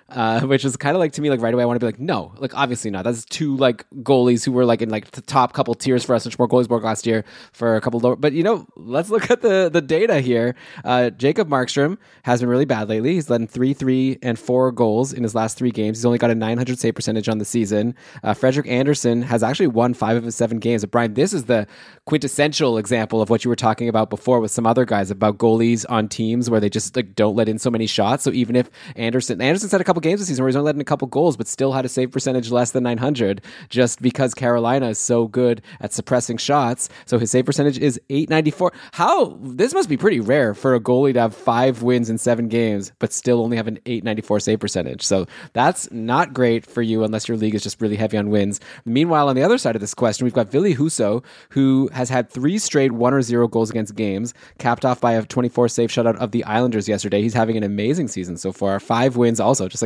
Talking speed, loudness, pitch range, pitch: 255 wpm, -19 LUFS, 115-130 Hz, 120 Hz